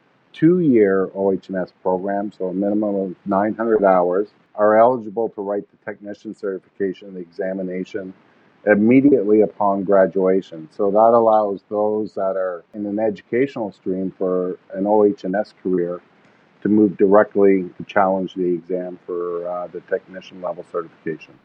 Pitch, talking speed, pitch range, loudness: 100 Hz, 135 wpm, 95-105 Hz, -19 LUFS